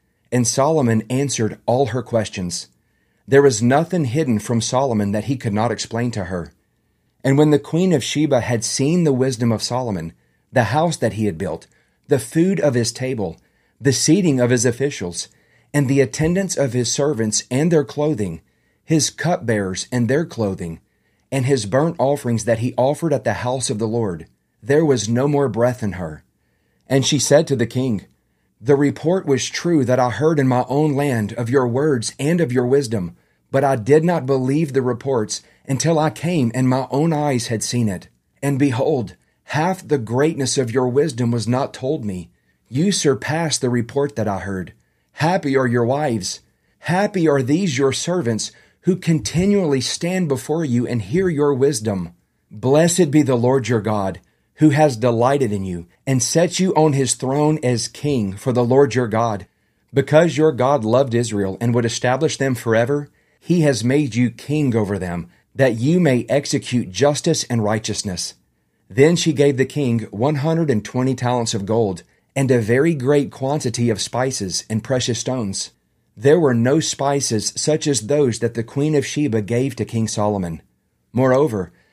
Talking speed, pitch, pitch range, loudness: 180 wpm, 130 Hz, 110-145 Hz, -19 LUFS